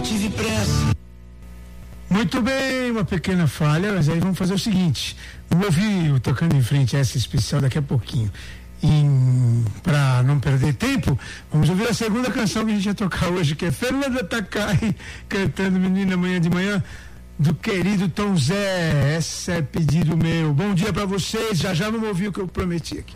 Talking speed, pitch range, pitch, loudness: 185 wpm, 140-200 Hz, 170 Hz, -21 LUFS